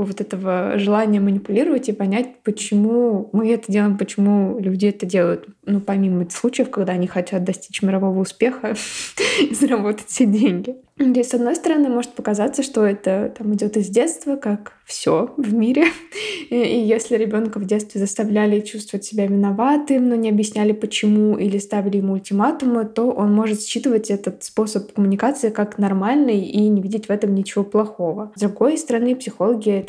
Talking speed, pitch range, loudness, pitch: 165 wpm, 200-240 Hz, -19 LUFS, 215 Hz